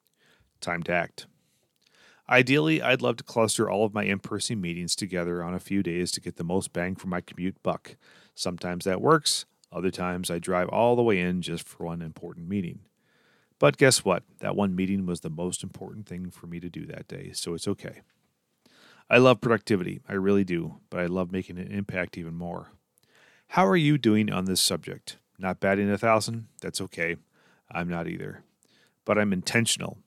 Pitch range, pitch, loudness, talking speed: 90-110 Hz, 95 Hz, -26 LUFS, 195 wpm